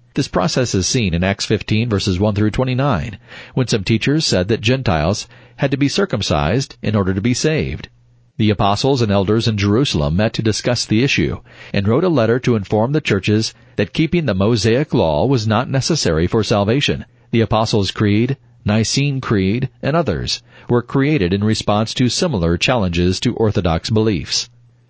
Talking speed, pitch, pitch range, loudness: 175 wpm, 115 Hz, 105-130 Hz, -17 LUFS